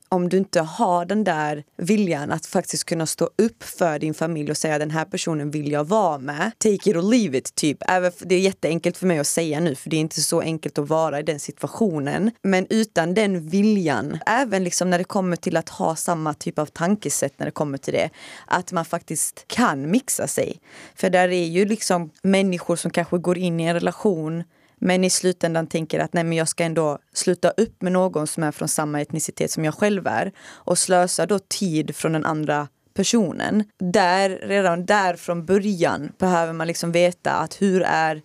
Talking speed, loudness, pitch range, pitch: 210 wpm, -22 LUFS, 160-190 Hz, 175 Hz